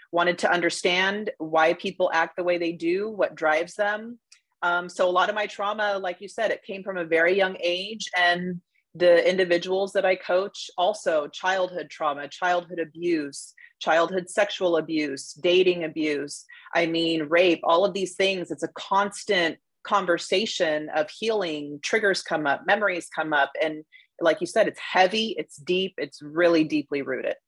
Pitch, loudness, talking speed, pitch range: 175 Hz, -24 LUFS, 170 wpm, 165-195 Hz